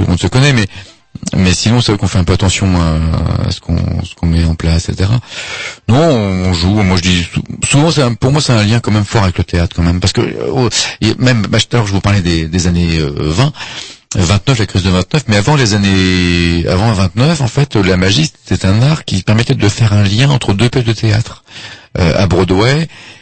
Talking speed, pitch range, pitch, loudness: 235 wpm, 90-120 Hz, 100 Hz, -12 LUFS